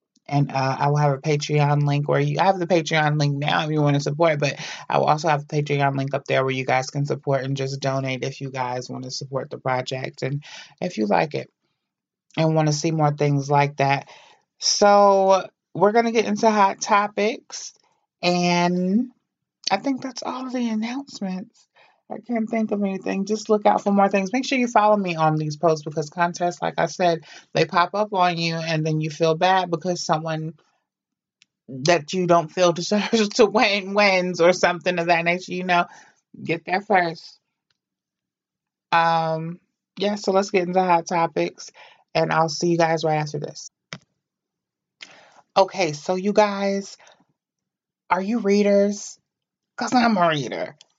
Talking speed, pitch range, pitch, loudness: 185 wpm, 150-200 Hz, 175 Hz, -21 LUFS